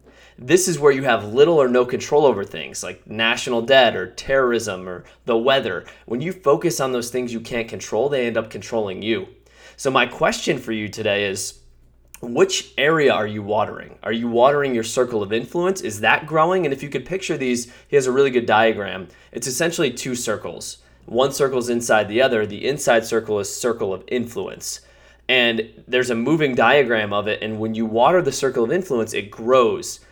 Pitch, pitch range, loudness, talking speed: 120 Hz, 110-135 Hz, -20 LUFS, 200 wpm